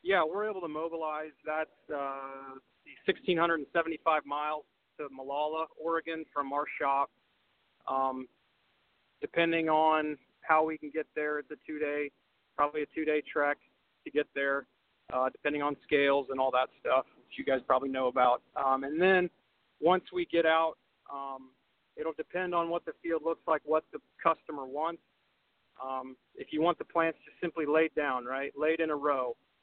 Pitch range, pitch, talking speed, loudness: 140-165 Hz, 150 Hz, 170 wpm, -32 LUFS